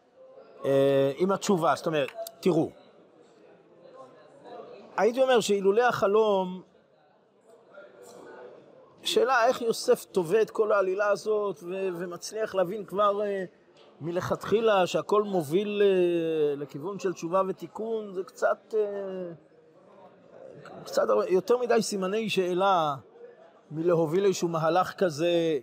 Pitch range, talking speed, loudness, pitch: 180-220 Hz, 100 wpm, -27 LUFS, 195 Hz